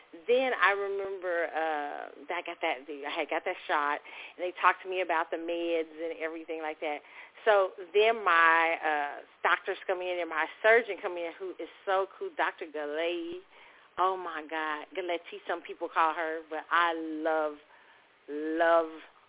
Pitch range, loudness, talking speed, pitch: 160-185 Hz, -30 LUFS, 175 wpm, 170 Hz